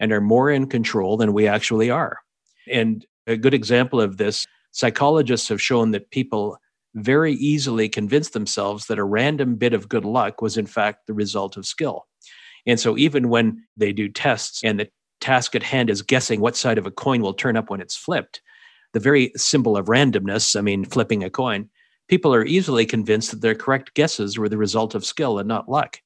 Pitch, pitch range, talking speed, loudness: 115 Hz, 105-135 Hz, 205 wpm, -20 LUFS